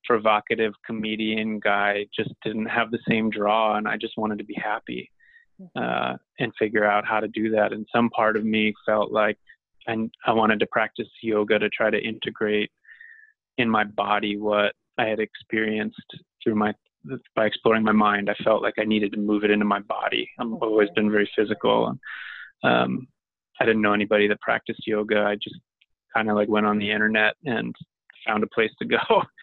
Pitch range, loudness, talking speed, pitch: 105-110 Hz, -23 LUFS, 190 wpm, 105 Hz